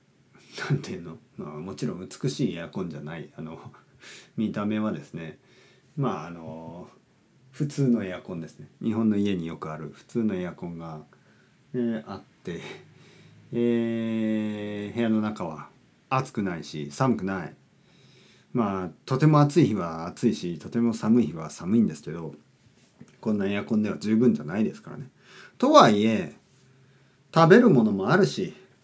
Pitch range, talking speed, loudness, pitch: 100-125 Hz, 300 characters per minute, -25 LUFS, 110 Hz